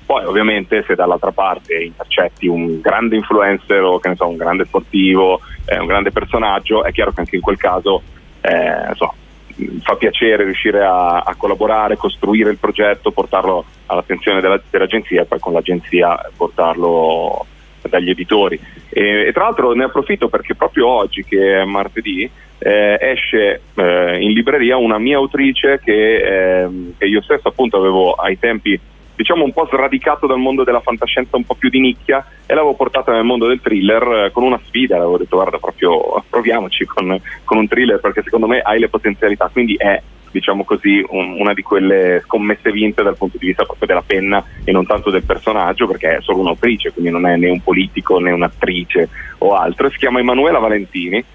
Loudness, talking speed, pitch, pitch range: -14 LUFS, 185 wpm, 100 Hz, 90-120 Hz